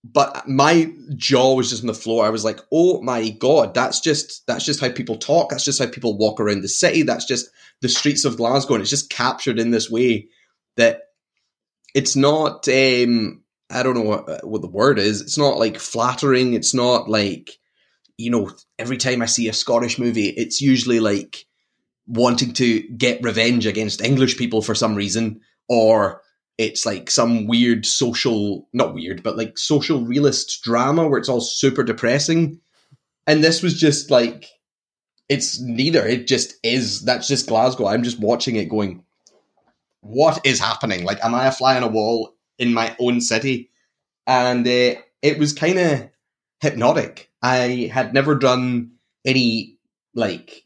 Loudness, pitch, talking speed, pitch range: -19 LUFS, 125 Hz, 175 wpm, 115-135 Hz